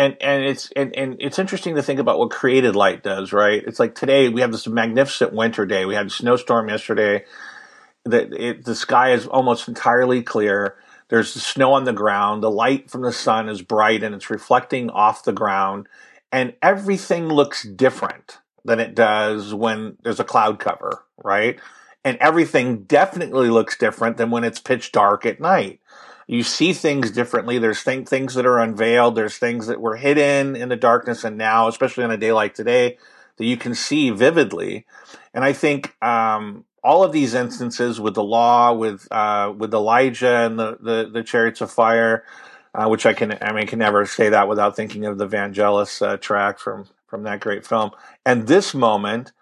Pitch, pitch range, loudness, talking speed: 115 Hz, 110-130 Hz, -19 LUFS, 195 wpm